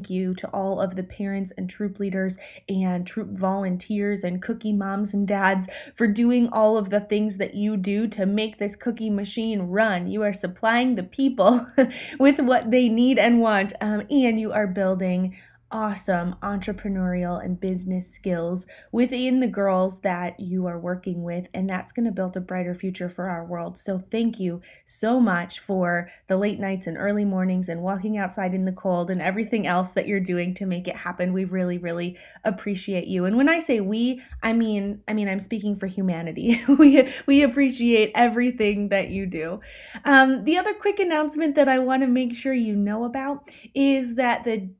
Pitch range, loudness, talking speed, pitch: 185-235 Hz, -23 LUFS, 195 wpm, 205 Hz